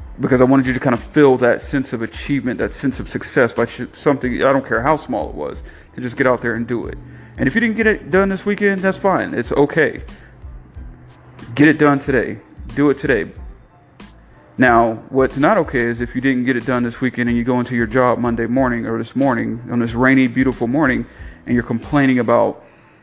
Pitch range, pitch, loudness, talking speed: 120-140 Hz, 125 Hz, -17 LUFS, 225 wpm